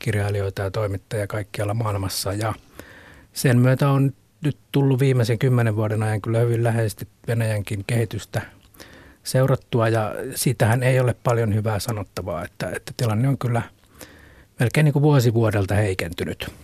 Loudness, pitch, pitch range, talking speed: -22 LUFS, 110 Hz, 100-125 Hz, 135 wpm